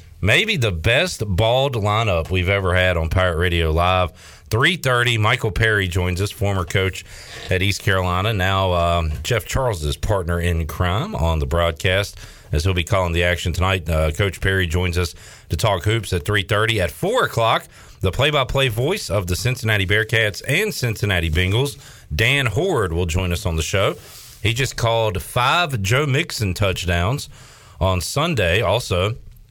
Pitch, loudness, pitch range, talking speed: 100 Hz, -19 LUFS, 90-115 Hz, 165 wpm